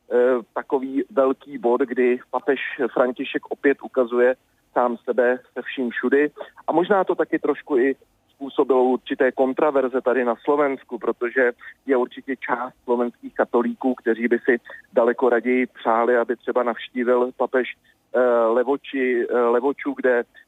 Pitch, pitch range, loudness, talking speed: 125 Hz, 120-140 Hz, -22 LUFS, 130 wpm